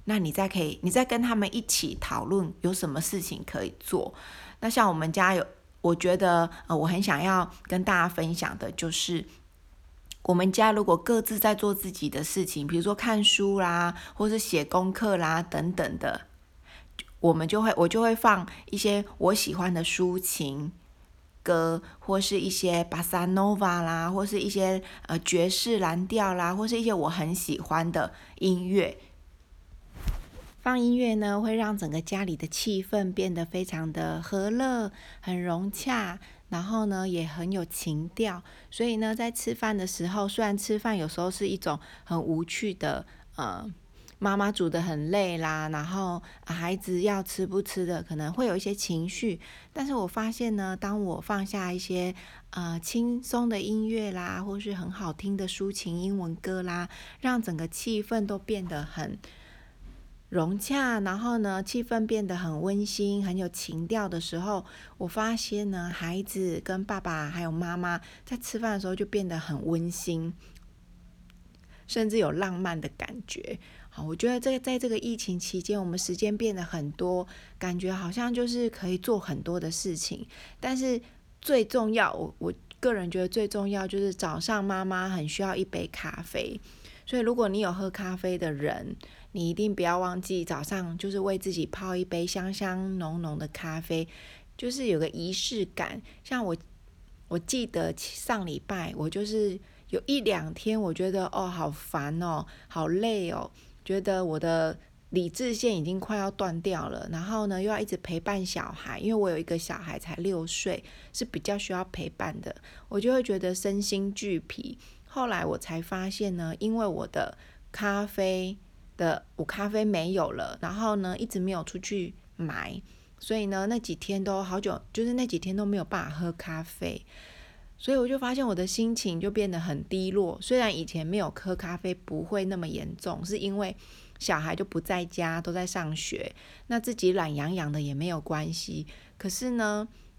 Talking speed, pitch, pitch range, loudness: 250 characters per minute, 185 Hz, 170-210 Hz, -30 LUFS